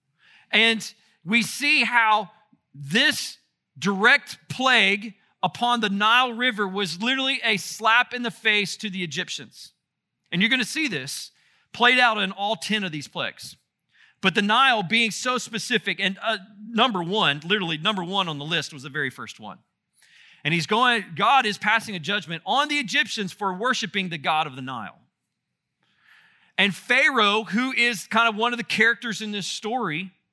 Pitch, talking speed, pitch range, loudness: 215 Hz, 170 wpm, 190-240 Hz, -22 LUFS